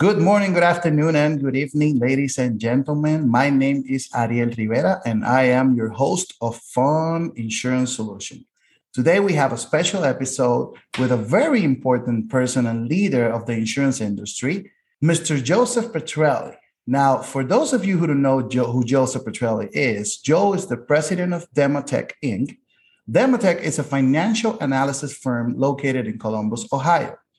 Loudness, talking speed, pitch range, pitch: -20 LUFS, 160 wpm, 125-155 Hz, 135 Hz